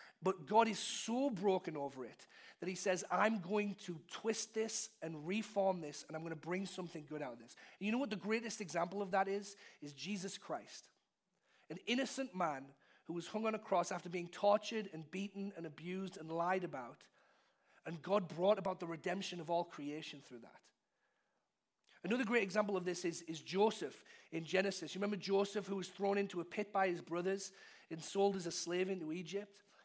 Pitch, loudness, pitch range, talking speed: 190 Hz, -40 LUFS, 170-205 Hz, 200 wpm